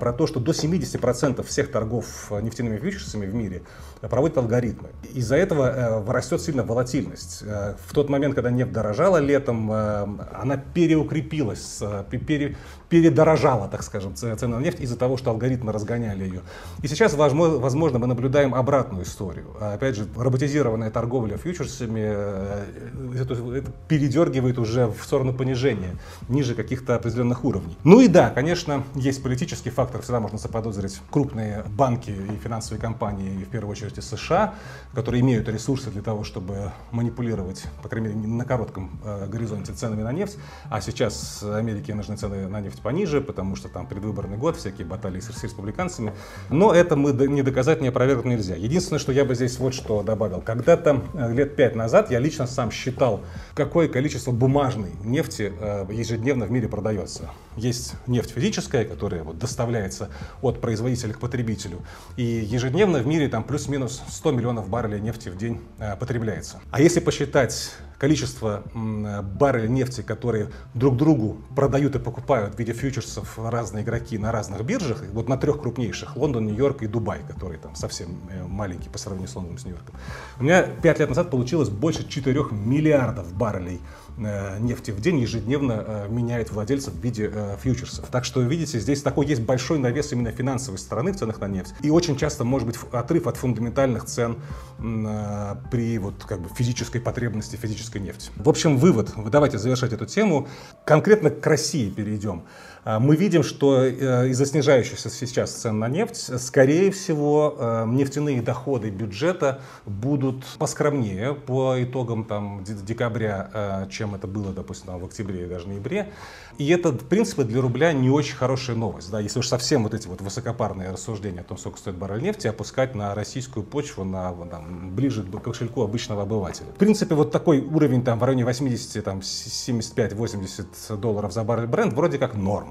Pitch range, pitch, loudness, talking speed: 105-135 Hz, 120 Hz, -24 LUFS, 160 wpm